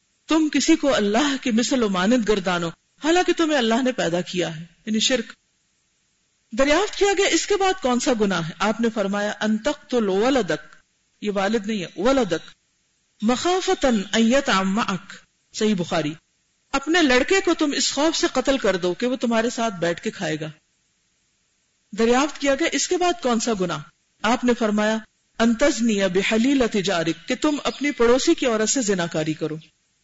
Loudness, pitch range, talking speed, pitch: -21 LUFS, 195-275 Hz, 165 wpm, 235 Hz